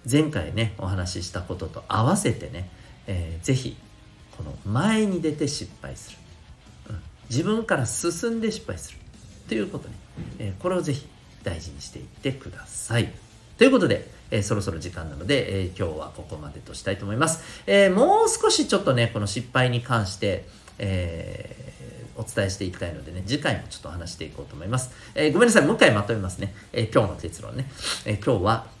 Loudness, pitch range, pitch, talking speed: -24 LUFS, 95-130 Hz, 110 Hz, 345 characters per minute